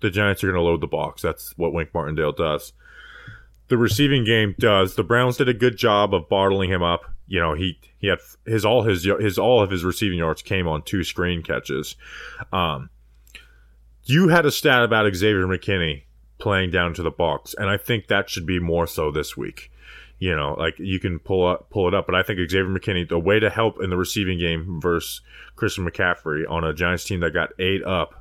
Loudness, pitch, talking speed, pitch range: -21 LUFS, 90 Hz, 220 wpm, 85-100 Hz